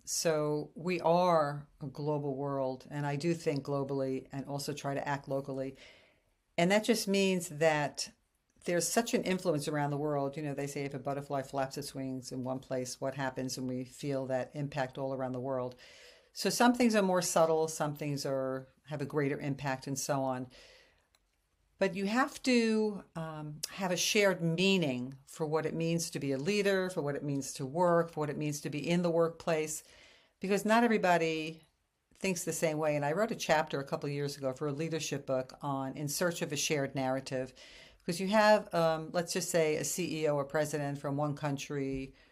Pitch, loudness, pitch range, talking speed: 150 Hz, -33 LUFS, 135-170 Hz, 205 wpm